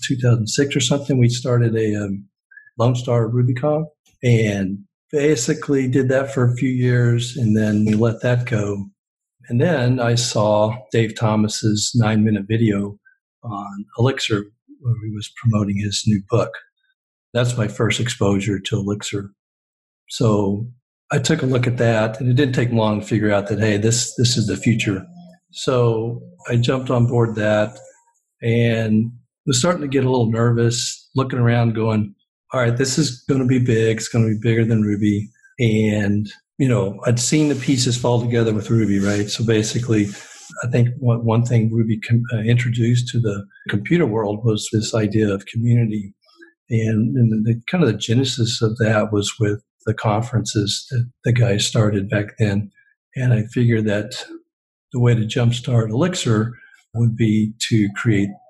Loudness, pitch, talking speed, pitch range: -19 LUFS, 115 Hz, 165 wpm, 110-125 Hz